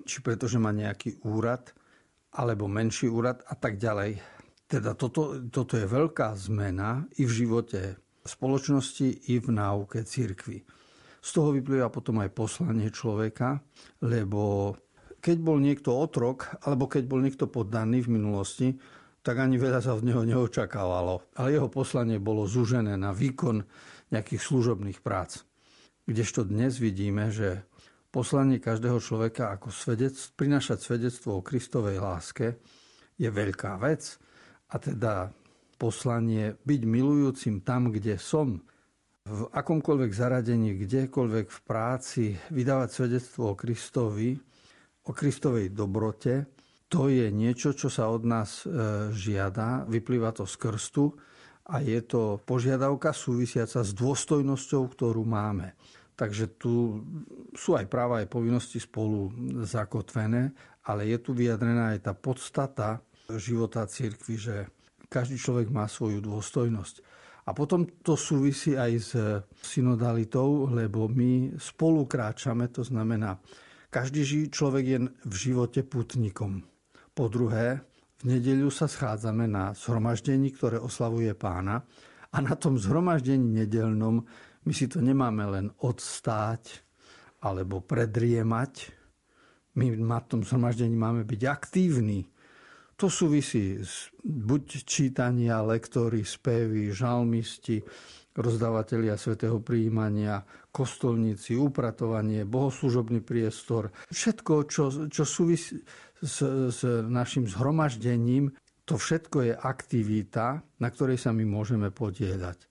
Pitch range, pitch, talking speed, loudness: 110-135 Hz, 120 Hz, 120 wpm, -29 LUFS